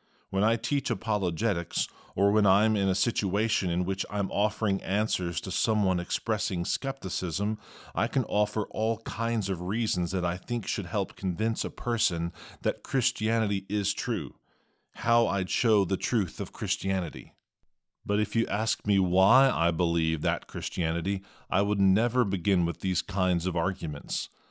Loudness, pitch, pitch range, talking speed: -28 LUFS, 100 Hz, 90-110 Hz, 155 wpm